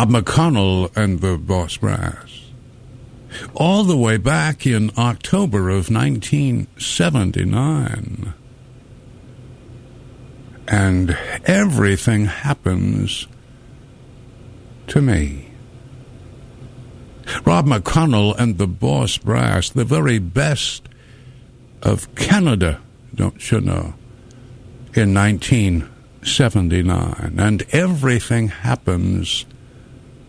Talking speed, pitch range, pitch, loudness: 75 wpm, 105-130 Hz, 120 Hz, -18 LUFS